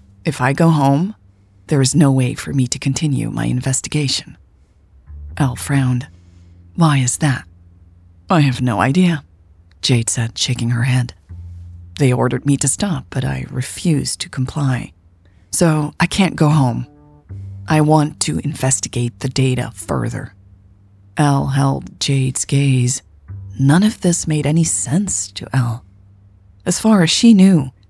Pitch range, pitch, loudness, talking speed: 95-145 Hz, 130 Hz, -16 LUFS, 145 wpm